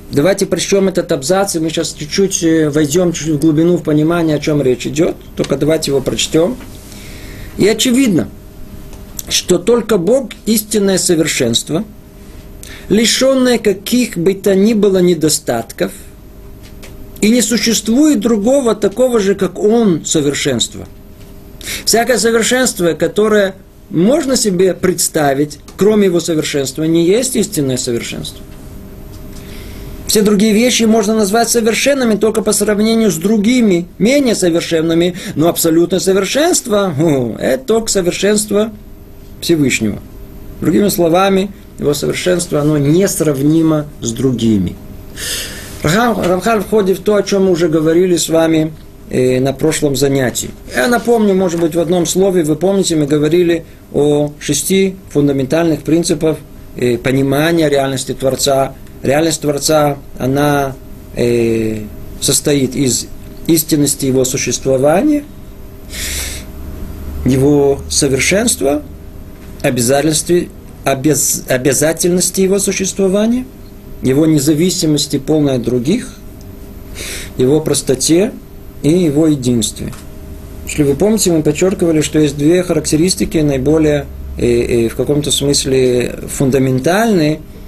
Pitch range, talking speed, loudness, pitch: 130-195 Hz, 110 wpm, -13 LUFS, 155 Hz